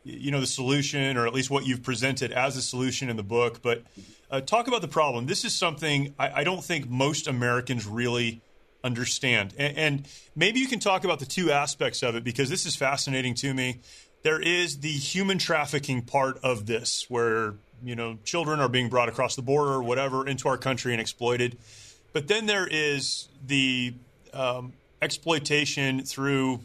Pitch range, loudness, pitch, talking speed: 120-150 Hz, -26 LUFS, 135 Hz, 190 wpm